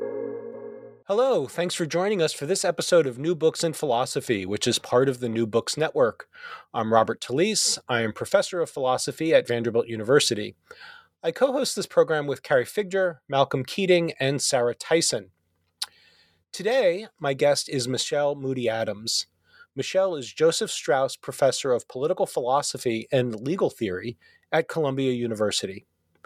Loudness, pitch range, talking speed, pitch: -24 LUFS, 125-200 Hz, 150 wpm, 155 Hz